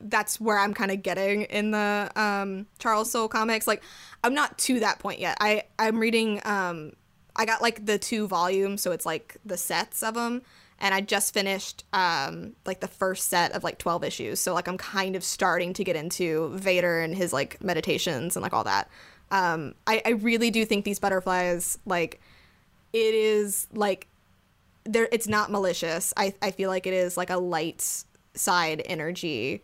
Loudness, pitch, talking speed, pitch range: -26 LUFS, 195 Hz, 190 wpm, 180-215 Hz